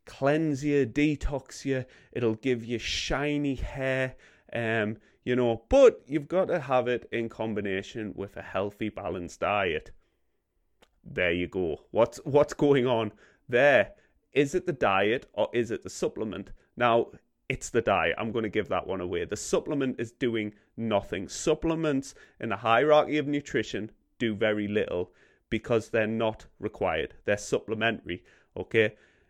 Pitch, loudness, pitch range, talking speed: 120 Hz, -28 LUFS, 110-145 Hz, 150 wpm